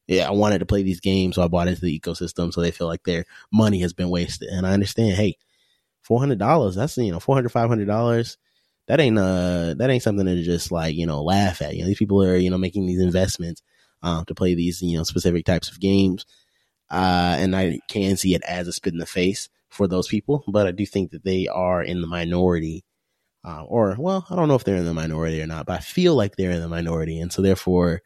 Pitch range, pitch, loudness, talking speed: 85-100 Hz, 90 Hz, -22 LUFS, 255 wpm